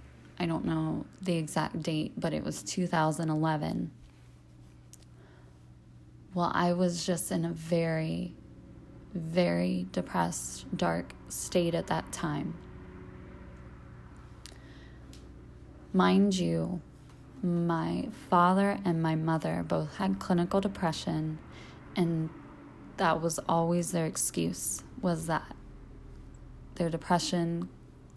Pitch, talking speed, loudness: 155 Hz, 95 wpm, -31 LUFS